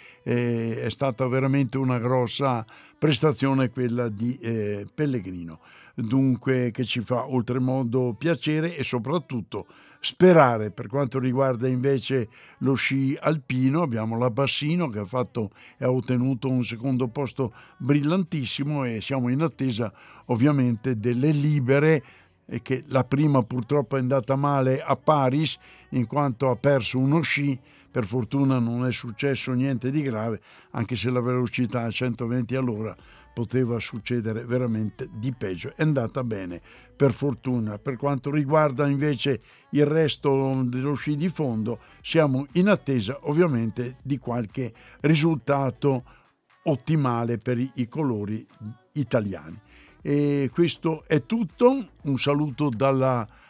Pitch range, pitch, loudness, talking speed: 120-140 Hz, 130 Hz, -25 LUFS, 130 wpm